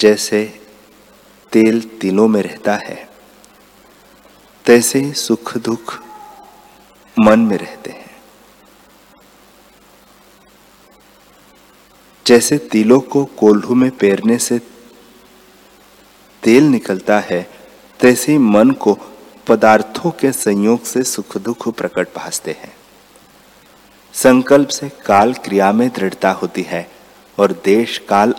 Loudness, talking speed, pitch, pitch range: -14 LUFS, 95 wpm, 115 Hz, 105-130 Hz